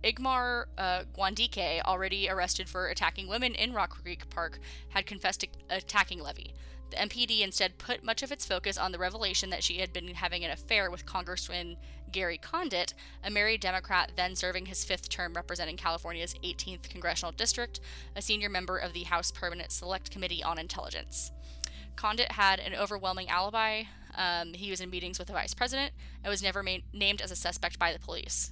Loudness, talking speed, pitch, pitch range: -32 LUFS, 185 wpm, 185 Hz, 175-205 Hz